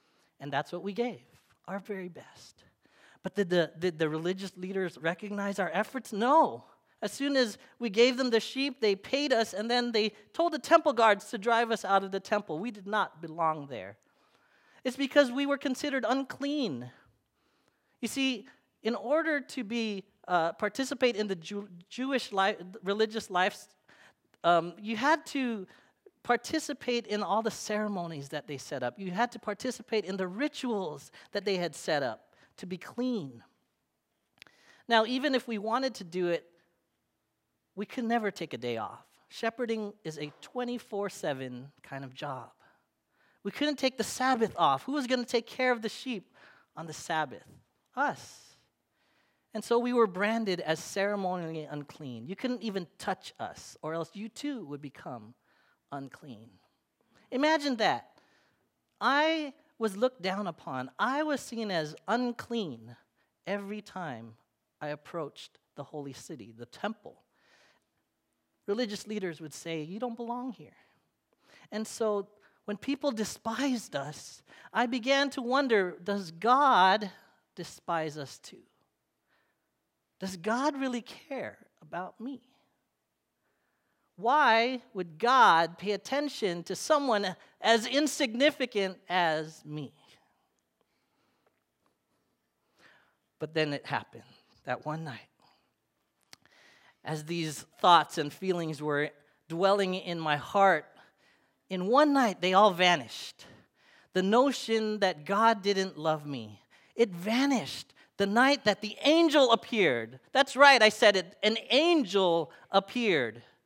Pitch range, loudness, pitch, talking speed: 170-245 Hz, -30 LUFS, 205 Hz, 140 wpm